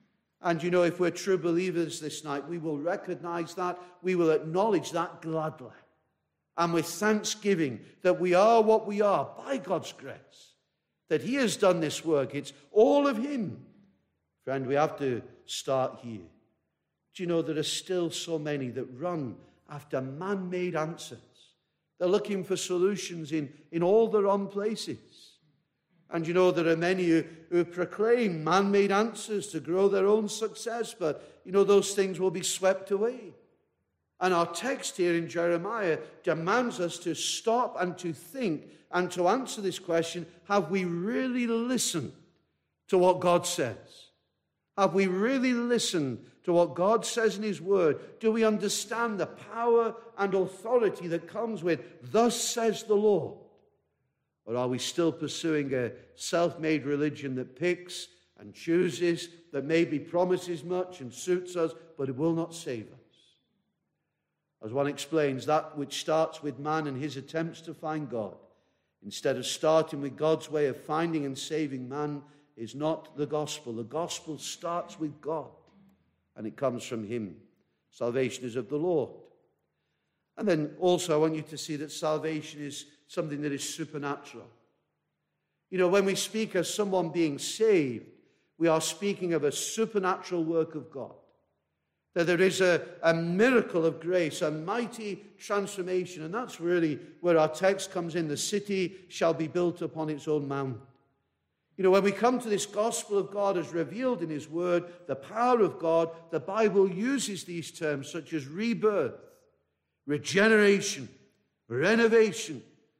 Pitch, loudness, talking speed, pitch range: 170 Hz, -29 LUFS, 165 wpm, 150-195 Hz